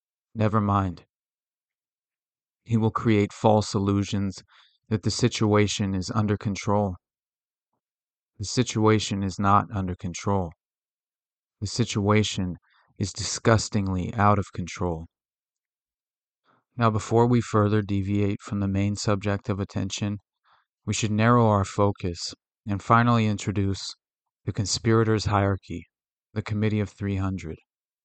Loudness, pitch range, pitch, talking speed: -25 LUFS, 100-110 Hz, 105 Hz, 110 wpm